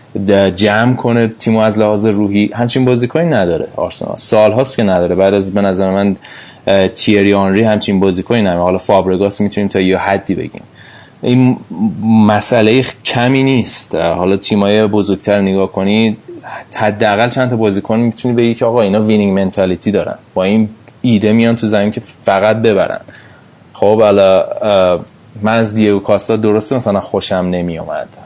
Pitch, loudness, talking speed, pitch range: 105 Hz, -12 LUFS, 150 wpm, 100-115 Hz